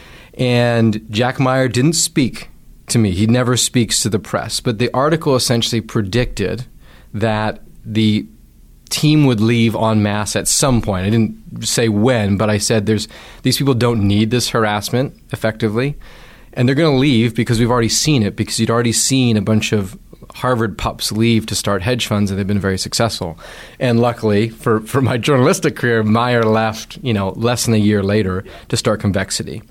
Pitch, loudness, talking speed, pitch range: 115 Hz, -16 LUFS, 180 wpm, 110-125 Hz